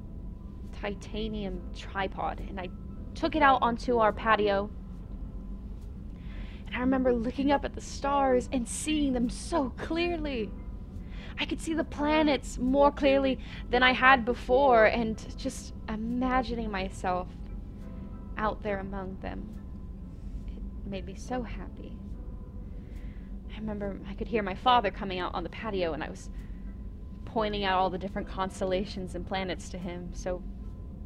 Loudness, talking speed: -29 LUFS, 140 wpm